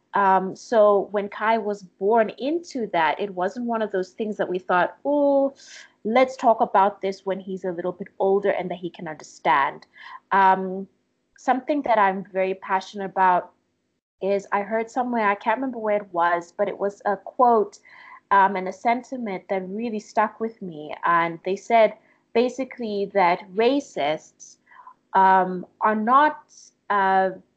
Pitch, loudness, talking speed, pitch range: 200 Hz, -23 LUFS, 160 wpm, 190-230 Hz